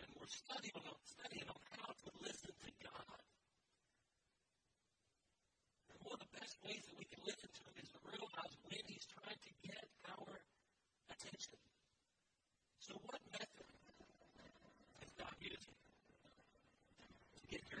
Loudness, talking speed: -55 LUFS, 140 wpm